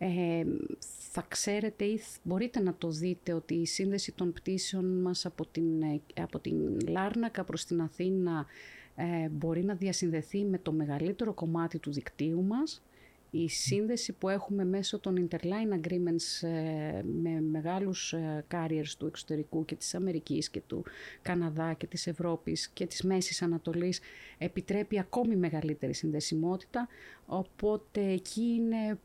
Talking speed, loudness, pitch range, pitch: 145 wpm, -34 LUFS, 160-195 Hz, 175 Hz